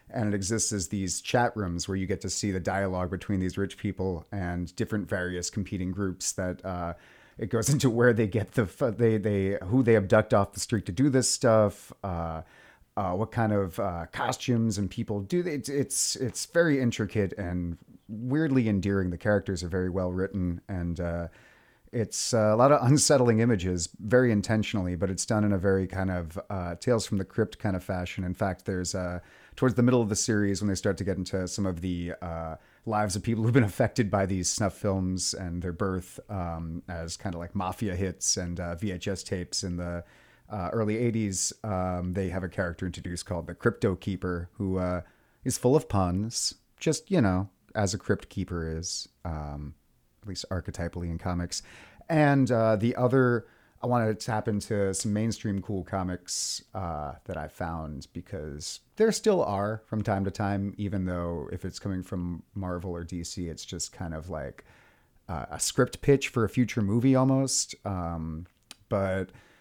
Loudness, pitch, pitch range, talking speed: -28 LUFS, 100 Hz, 90-110 Hz, 190 wpm